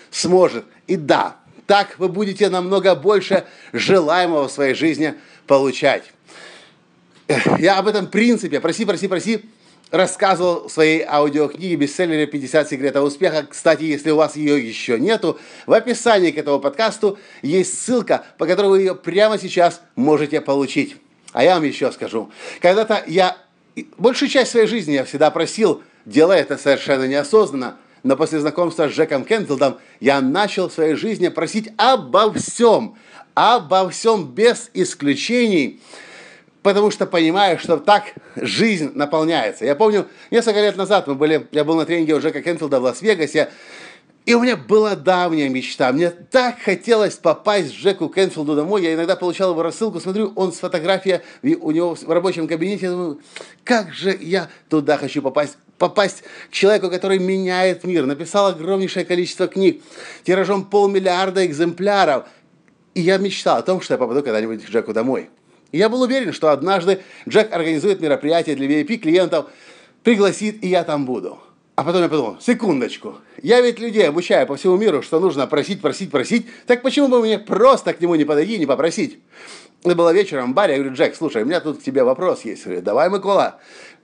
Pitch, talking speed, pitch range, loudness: 185 Hz, 165 wpm, 155-210 Hz, -18 LUFS